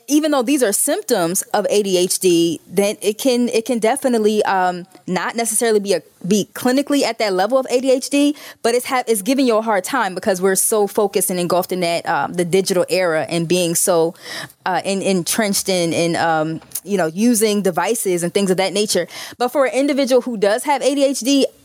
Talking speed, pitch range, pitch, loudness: 200 wpm, 180-250 Hz, 205 Hz, -17 LUFS